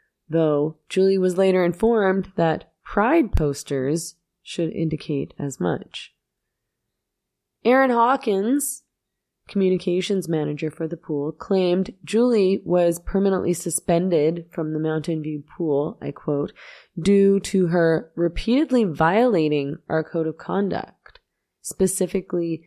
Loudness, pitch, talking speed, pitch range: -22 LUFS, 175 Hz, 110 wpm, 160-195 Hz